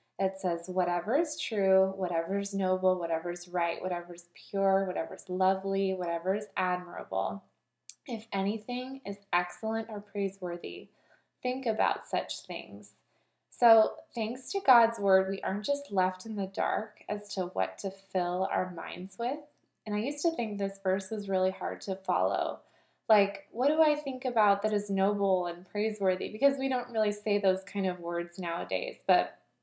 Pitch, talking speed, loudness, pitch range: 195 Hz, 170 wpm, -30 LUFS, 185-220 Hz